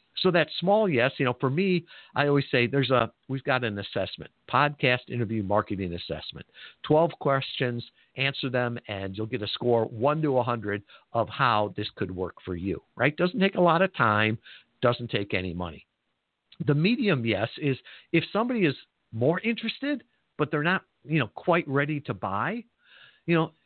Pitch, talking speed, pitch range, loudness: 135 Hz, 180 wpm, 115-160 Hz, -27 LUFS